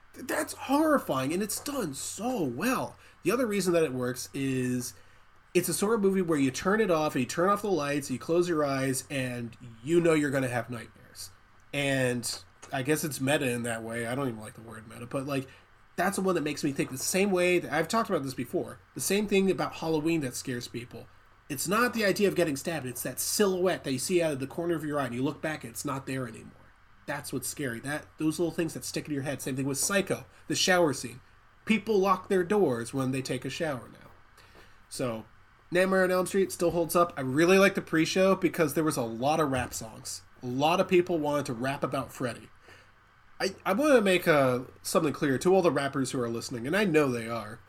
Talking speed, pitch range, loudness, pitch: 240 wpm, 125-175 Hz, -28 LUFS, 140 Hz